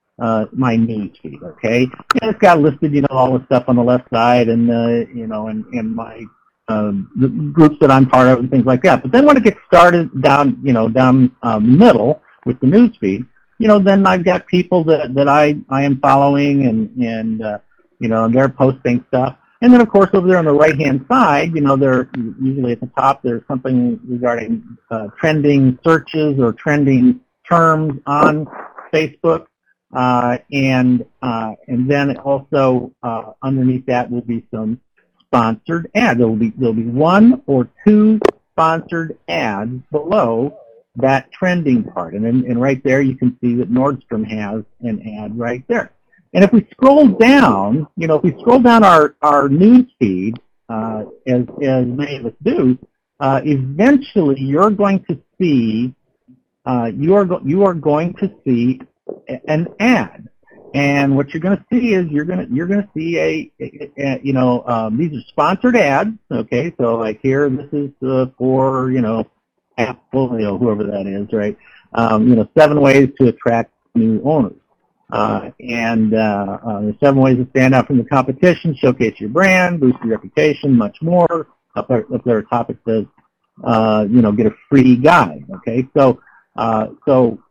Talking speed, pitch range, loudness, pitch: 180 wpm, 120-155 Hz, -14 LUFS, 130 Hz